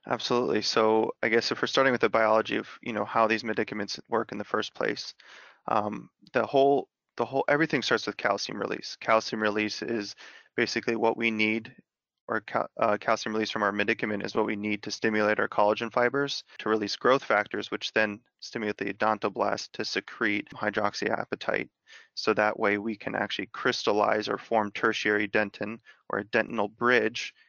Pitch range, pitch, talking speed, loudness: 105-115 Hz, 110 Hz, 180 wpm, -28 LUFS